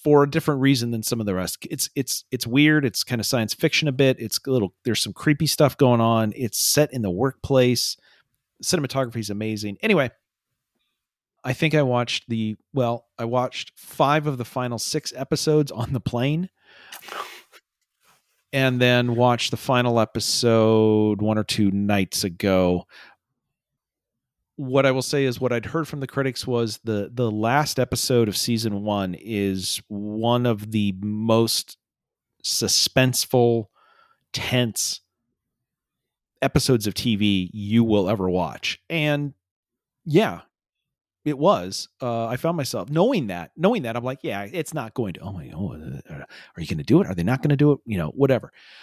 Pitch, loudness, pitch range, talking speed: 120 Hz, -22 LUFS, 110-135 Hz, 170 wpm